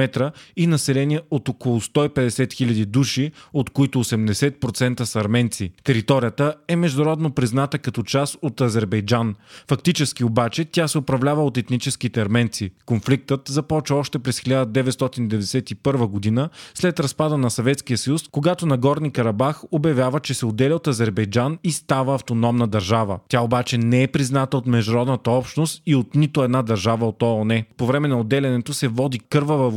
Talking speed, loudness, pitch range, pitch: 150 wpm, -21 LUFS, 120-145 Hz, 130 Hz